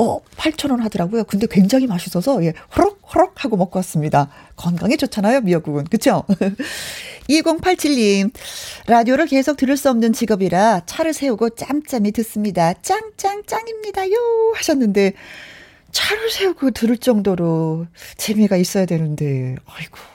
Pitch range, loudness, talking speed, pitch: 190-300 Hz, -18 LUFS, 305 characters per minute, 230 Hz